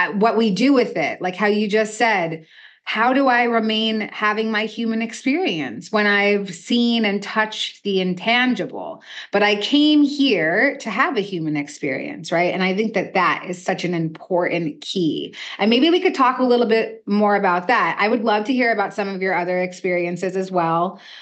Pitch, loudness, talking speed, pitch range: 210 Hz, -19 LUFS, 195 wpm, 185-235 Hz